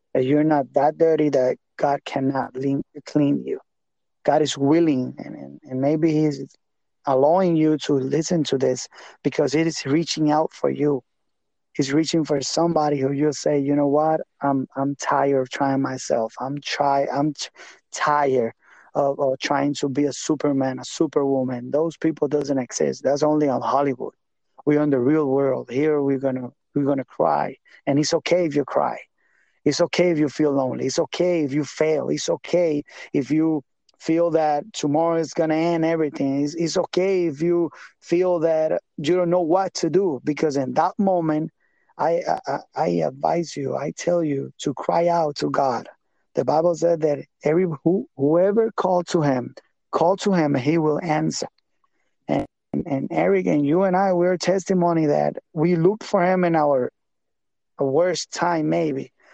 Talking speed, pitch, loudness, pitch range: 175 wpm, 150 Hz, -22 LUFS, 140-170 Hz